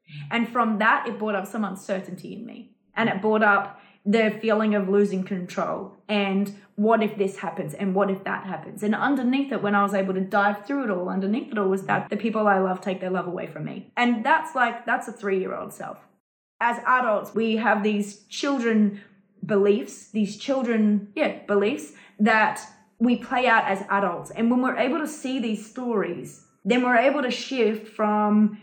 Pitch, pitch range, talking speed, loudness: 210 Hz, 200-230 Hz, 195 wpm, -24 LUFS